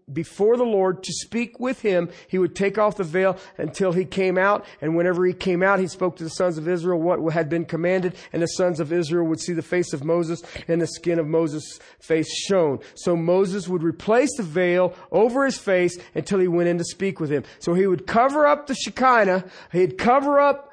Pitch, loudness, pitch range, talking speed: 180 Hz, -22 LUFS, 170-200 Hz, 225 wpm